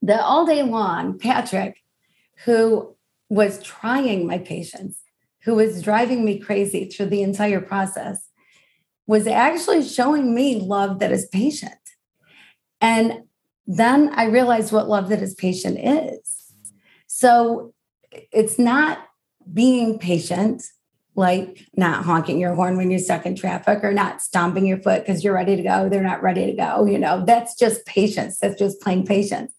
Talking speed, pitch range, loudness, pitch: 155 wpm, 190-235 Hz, -20 LUFS, 210 Hz